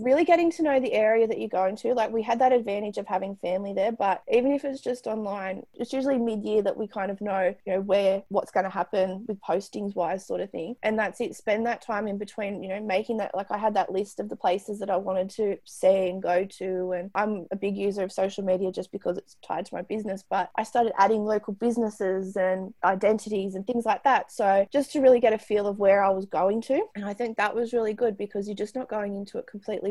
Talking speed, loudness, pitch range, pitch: 260 wpm, -26 LUFS, 190-225 Hz, 205 Hz